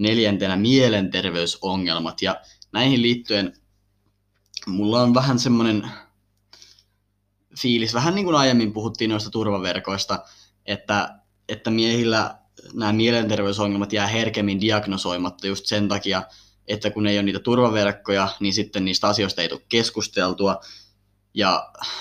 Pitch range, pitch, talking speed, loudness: 100-110 Hz, 100 Hz, 115 wpm, -21 LUFS